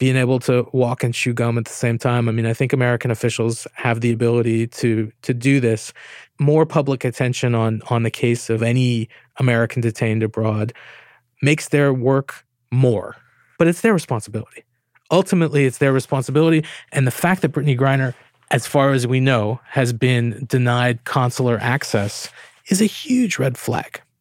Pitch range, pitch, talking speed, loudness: 115-140 Hz, 125 Hz, 170 wpm, -19 LUFS